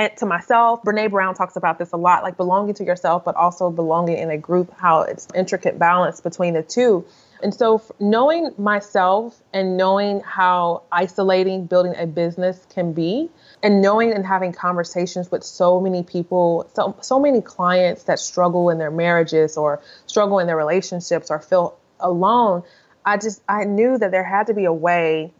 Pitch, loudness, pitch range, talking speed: 180 Hz, -19 LUFS, 175-205 Hz, 180 wpm